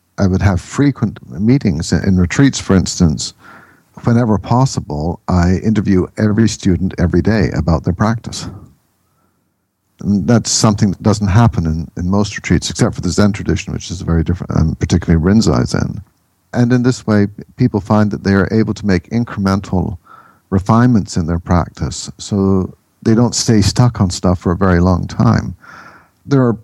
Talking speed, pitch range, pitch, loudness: 165 wpm, 90-110 Hz, 100 Hz, -15 LUFS